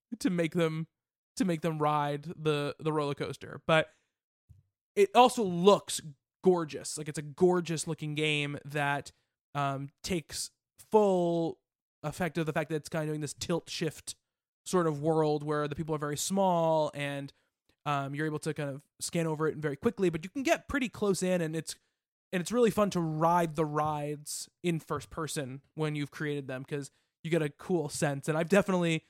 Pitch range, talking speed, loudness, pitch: 145-175 Hz, 190 wpm, -31 LUFS, 155 Hz